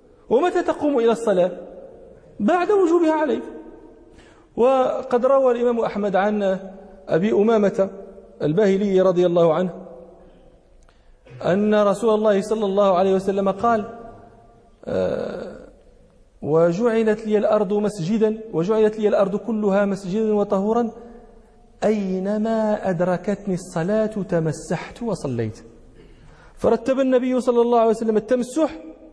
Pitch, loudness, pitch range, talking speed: 210 Hz, -20 LUFS, 190-230 Hz, 100 wpm